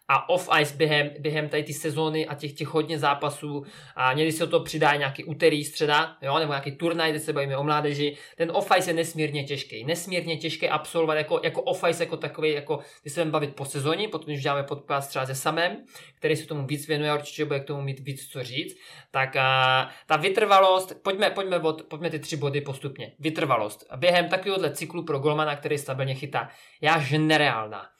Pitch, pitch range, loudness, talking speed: 155 Hz, 145-160 Hz, -25 LUFS, 210 wpm